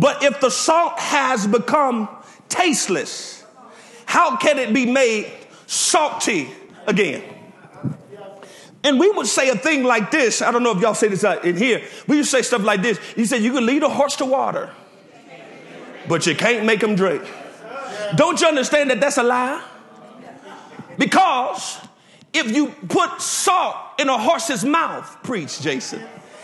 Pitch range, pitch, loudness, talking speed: 220-290 Hz, 255 Hz, -18 LUFS, 160 wpm